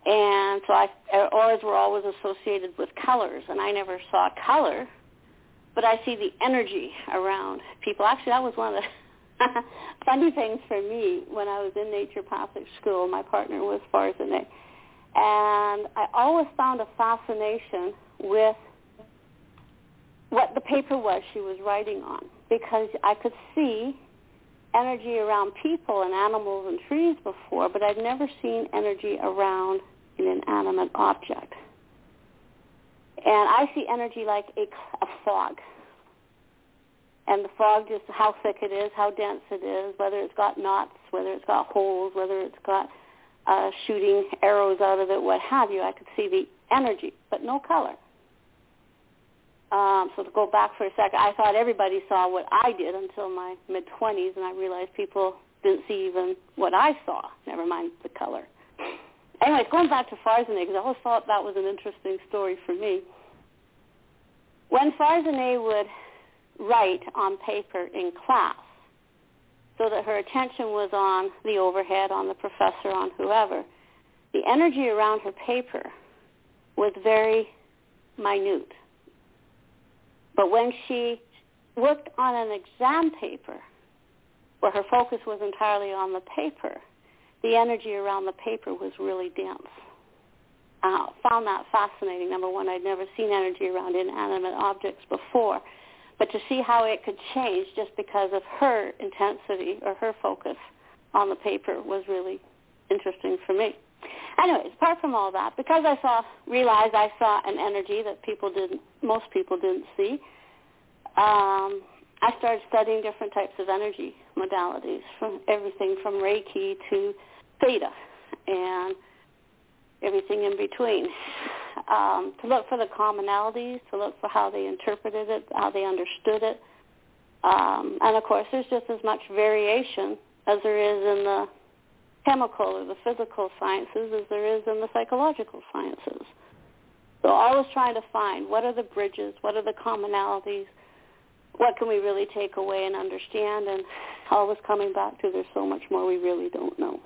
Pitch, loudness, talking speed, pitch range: 215 Hz, -26 LUFS, 155 wpm, 195-255 Hz